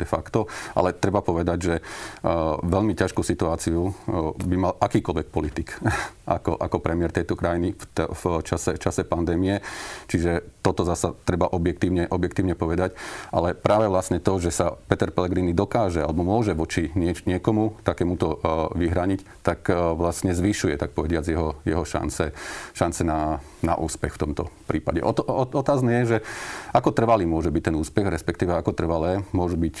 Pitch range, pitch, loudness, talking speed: 85-100 Hz, 90 Hz, -24 LUFS, 155 wpm